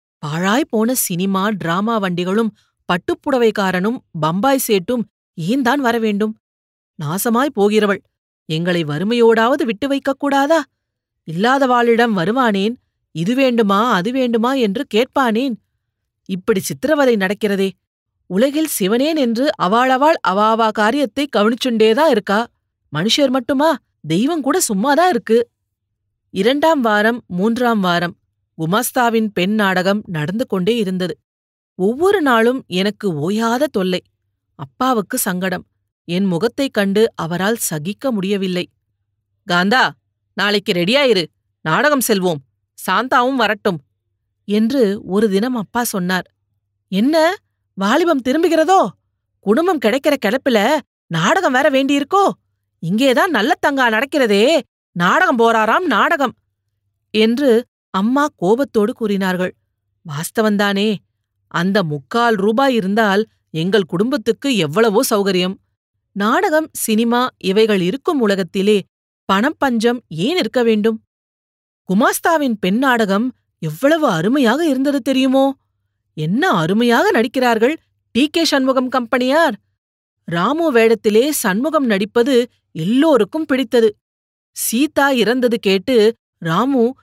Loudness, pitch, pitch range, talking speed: -16 LUFS, 220 Hz, 185-260 Hz, 95 wpm